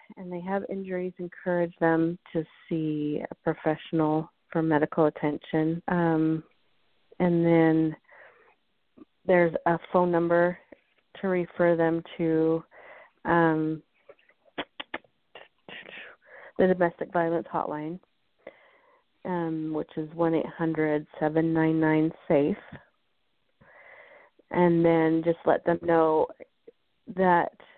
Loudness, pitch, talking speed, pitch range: -26 LUFS, 165 Hz, 95 wpm, 160-175 Hz